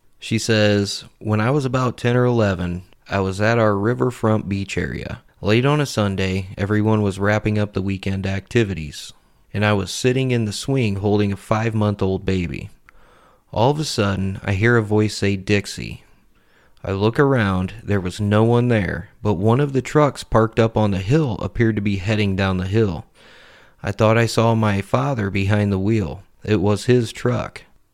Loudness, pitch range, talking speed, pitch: -20 LUFS, 100-115 Hz, 190 wpm, 105 Hz